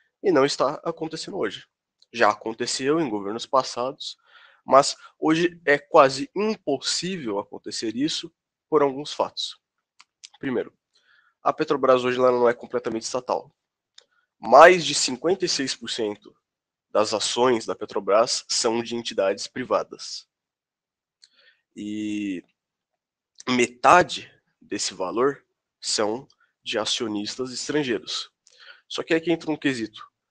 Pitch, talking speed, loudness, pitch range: 140 Hz, 105 wpm, -23 LUFS, 120-170 Hz